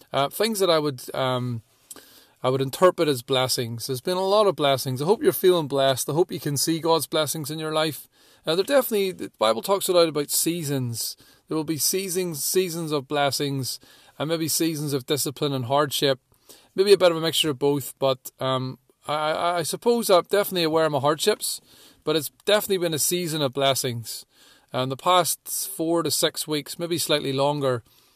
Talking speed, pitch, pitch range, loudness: 200 wpm, 150 Hz, 135-175 Hz, -23 LUFS